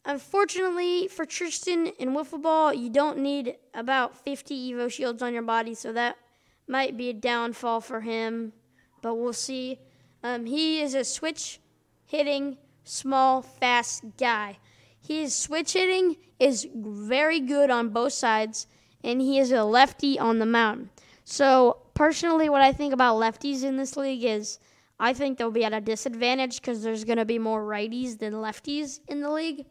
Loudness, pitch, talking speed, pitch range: -26 LUFS, 260 Hz, 160 wpm, 230-290 Hz